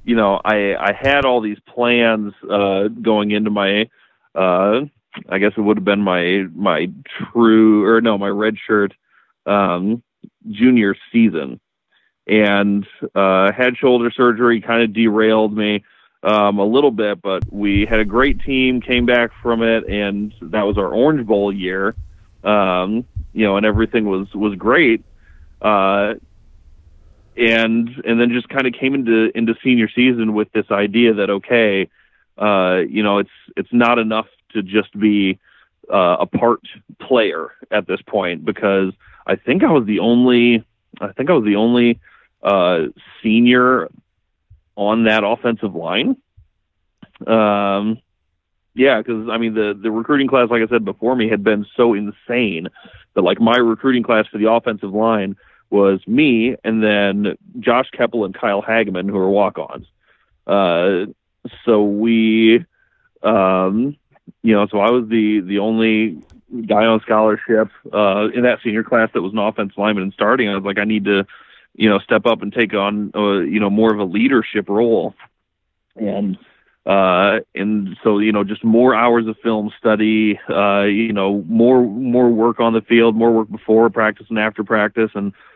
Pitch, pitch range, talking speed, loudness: 110 Hz, 100-115 Hz, 165 wpm, -16 LUFS